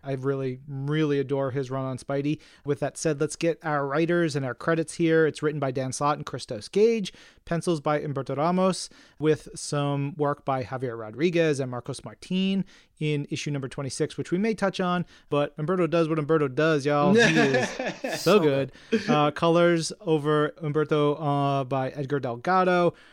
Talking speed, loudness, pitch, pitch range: 175 wpm, -26 LUFS, 150 Hz, 140-165 Hz